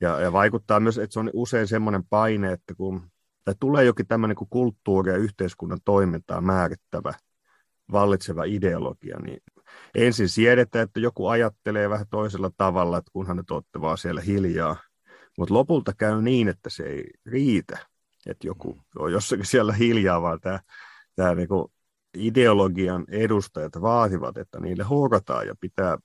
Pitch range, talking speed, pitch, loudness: 95-115 Hz, 145 wpm, 100 Hz, -24 LUFS